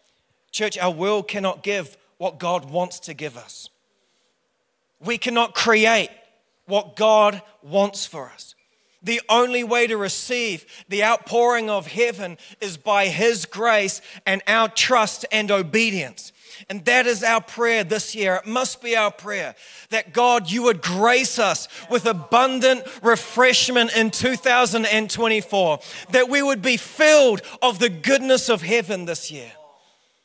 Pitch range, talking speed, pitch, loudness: 200-240 Hz, 145 wpm, 225 Hz, -20 LUFS